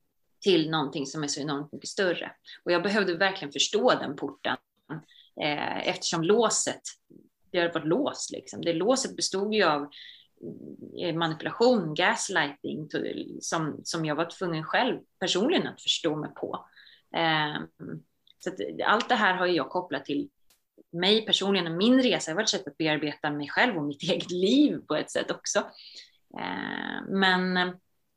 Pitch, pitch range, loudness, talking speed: 175 Hz, 155-195 Hz, -27 LUFS, 160 wpm